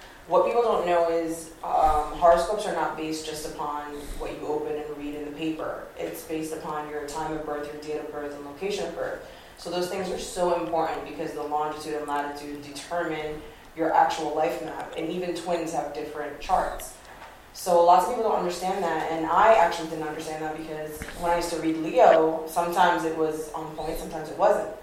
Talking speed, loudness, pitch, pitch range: 205 wpm, -26 LUFS, 160 Hz, 150-170 Hz